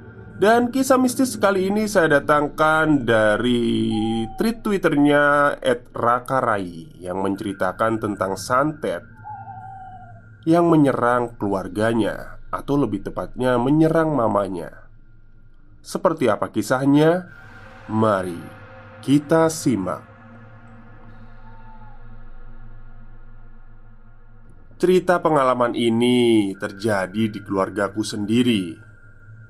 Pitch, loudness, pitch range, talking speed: 115 Hz, -20 LUFS, 110-145 Hz, 75 wpm